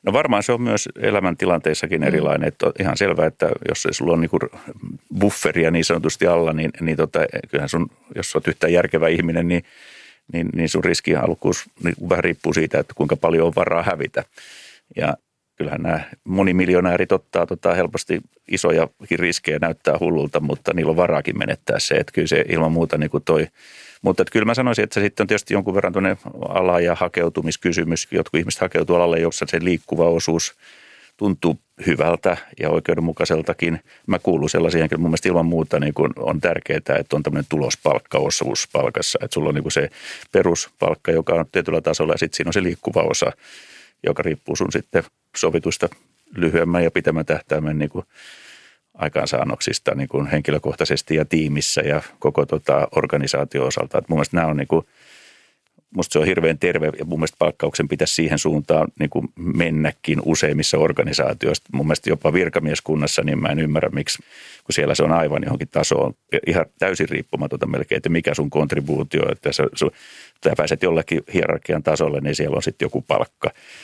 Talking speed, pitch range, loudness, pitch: 175 wpm, 80-90 Hz, -20 LUFS, 85 Hz